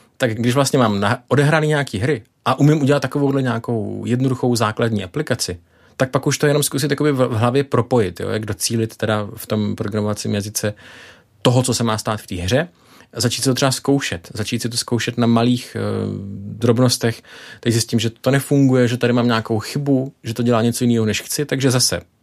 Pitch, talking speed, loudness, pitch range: 120 Hz, 195 wpm, -19 LUFS, 110-130 Hz